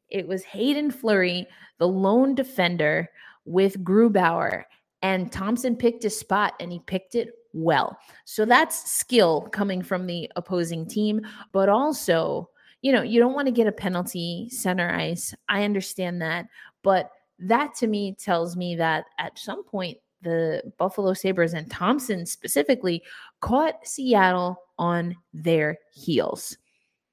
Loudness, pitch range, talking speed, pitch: -24 LUFS, 175-230 Hz, 140 wpm, 190 Hz